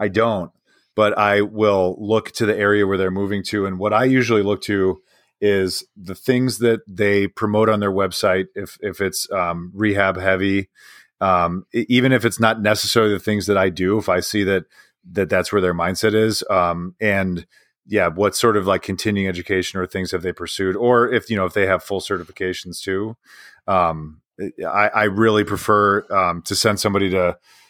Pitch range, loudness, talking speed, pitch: 95-110 Hz, -19 LUFS, 195 wpm, 100 Hz